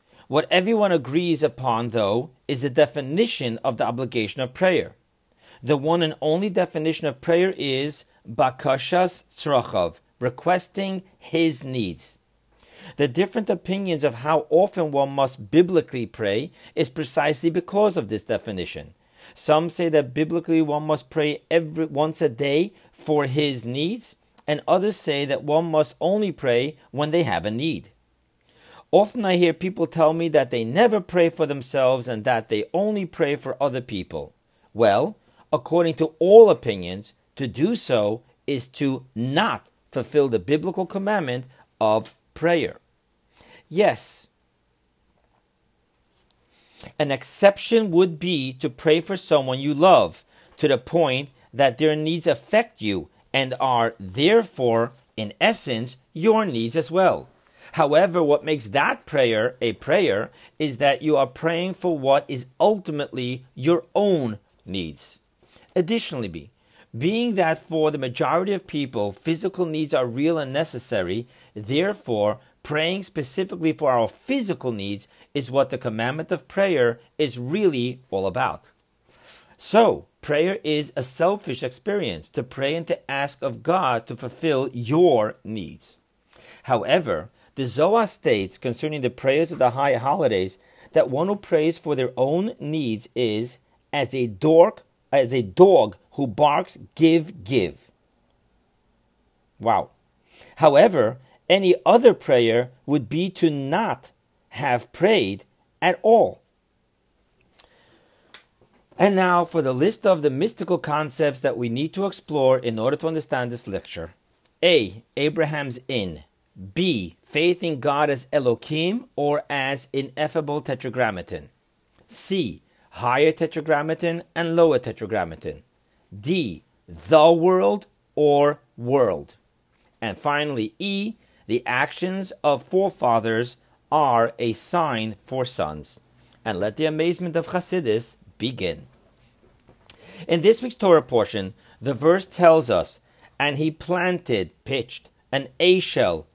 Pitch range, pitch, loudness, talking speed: 125-170 Hz, 150 Hz, -22 LUFS, 130 wpm